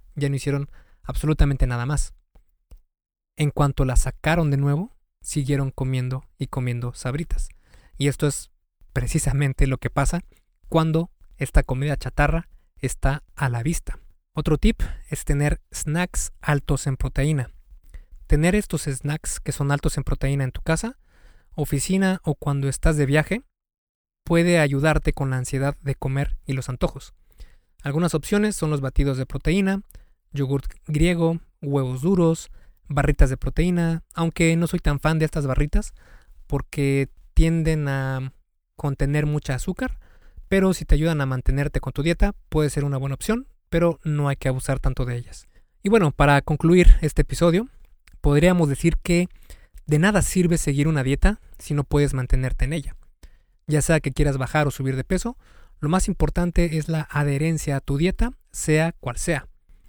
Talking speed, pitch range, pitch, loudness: 160 wpm, 135-165 Hz, 145 Hz, -23 LUFS